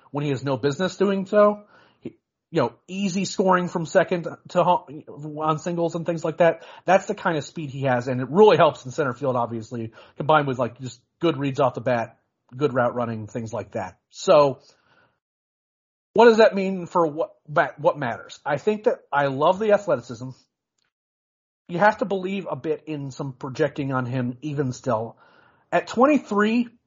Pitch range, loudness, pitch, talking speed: 130-190 Hz, -23 LUFS, 155 Hz, 190 wpm